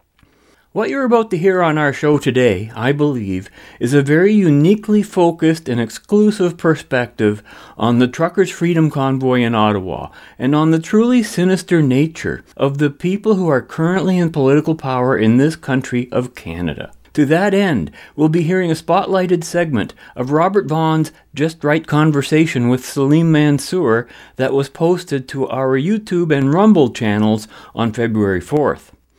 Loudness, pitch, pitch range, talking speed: -16 LUFS, 150 Hz, 125-175 Hz, 155 wpm